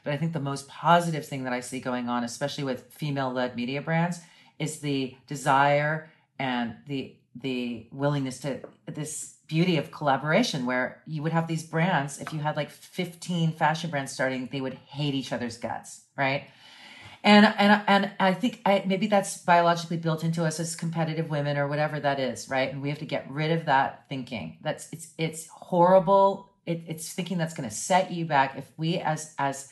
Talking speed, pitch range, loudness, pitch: 195 wpm, 135-165 Hz, -27 LUFS, 150 Hz